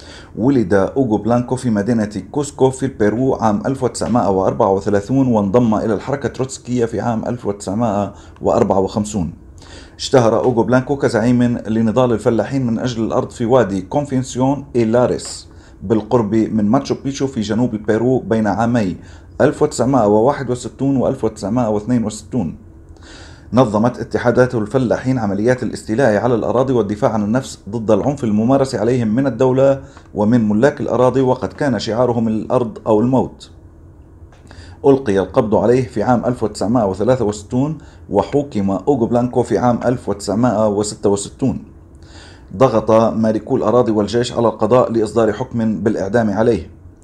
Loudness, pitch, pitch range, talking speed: -16 LUFS, 115 Hz, 105-125 Hz, 110 wpm